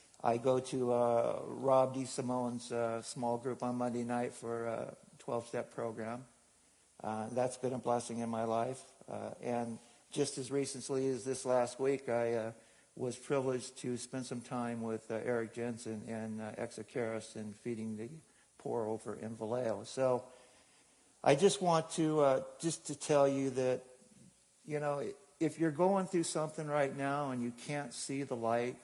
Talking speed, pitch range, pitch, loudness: 170 wpm, 115-140 Hz, 125 Hz, -36 LUFS